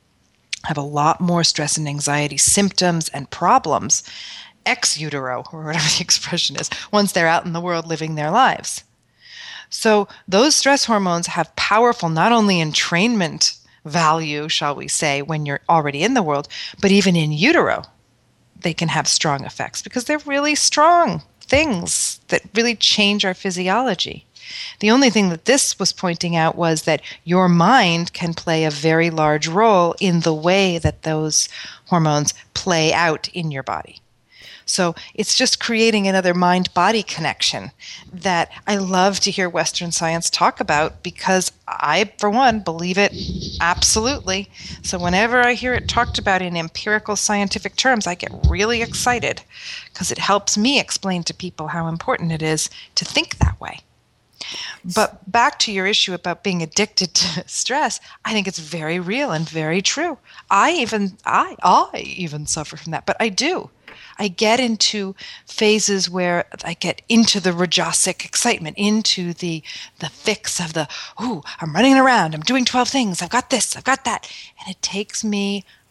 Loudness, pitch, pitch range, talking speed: -18 LUFS, 185 Hz, 165-215 Hz, 165 wpm